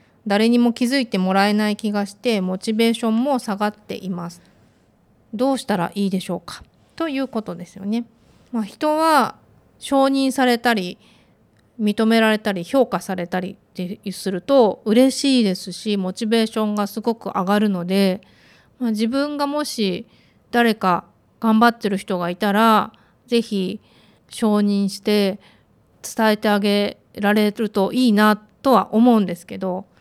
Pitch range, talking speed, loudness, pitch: 195-235 Hz, 295 characters per minute, -20 LUFS, 215 Hz